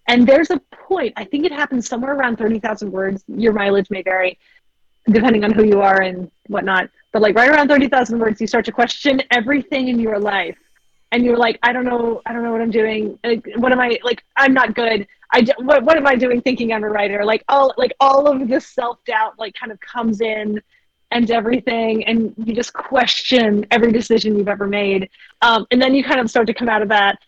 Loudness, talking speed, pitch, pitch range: -16 LUFS, 235 wpm, 235 Hz, 215-255 Hz